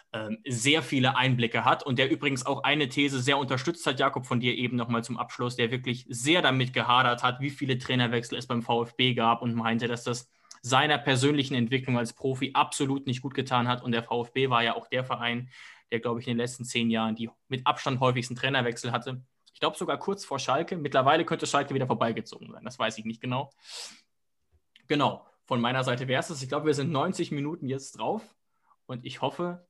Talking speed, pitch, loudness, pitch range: 210 wpm, 130 Hz, -28 LUFS, 120-140 Hz